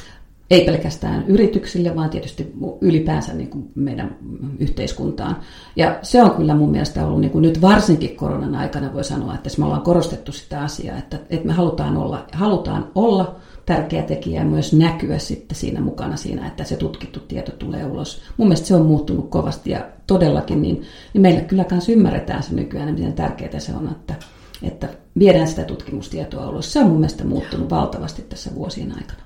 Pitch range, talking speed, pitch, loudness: 140-185 Hz, 170 wpm, 165 Hz, -19 LUFS